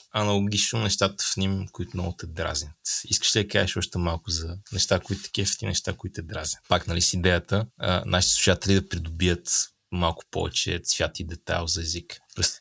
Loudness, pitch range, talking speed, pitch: -25 LUFS, 85-100 Hz, 185 wpm, 95 Hz